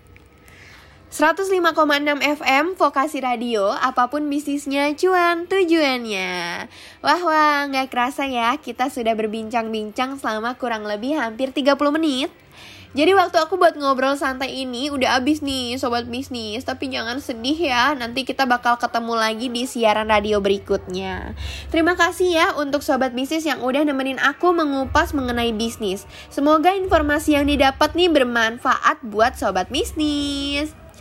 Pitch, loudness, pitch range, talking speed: 270 Hz, -20 LUFS, 235-300 Hz, 135 wpm